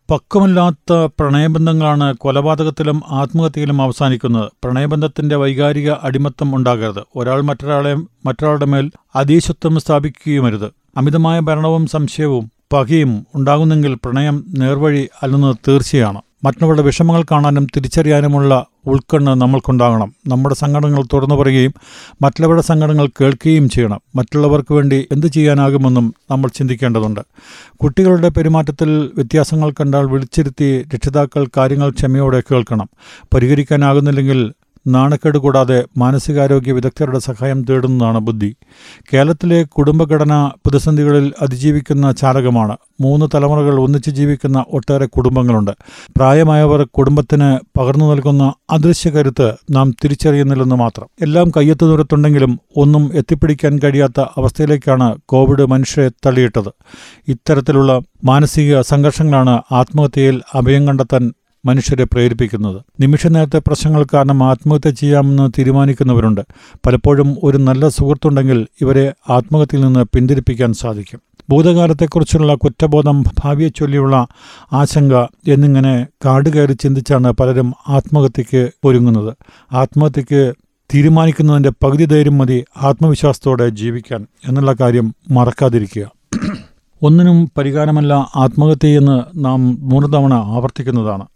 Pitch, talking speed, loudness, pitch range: 140 Hz, 95 wpm, -13 LUFS, 130-150 Hz